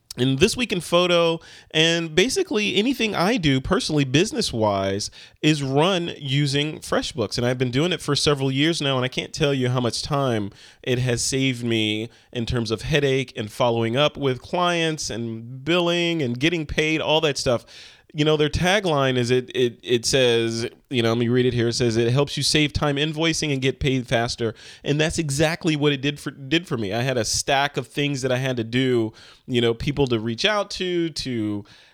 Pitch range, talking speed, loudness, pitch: 120-155 Hz, 210 wpm, -22 LUFS, 140 Hz